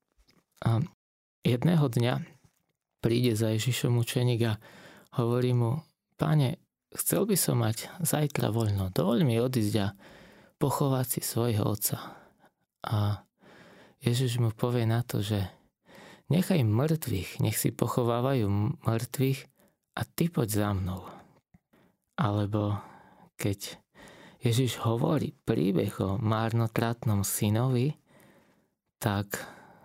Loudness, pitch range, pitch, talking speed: -29 LUFS, 110-140 Hz, 120 Hz, 105 wpm